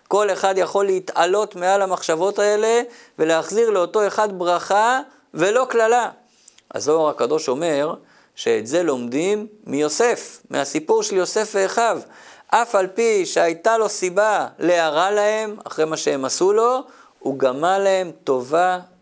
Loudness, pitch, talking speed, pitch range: -19 LUFS, 205 Hz, 130 wpm, 180-230 Hz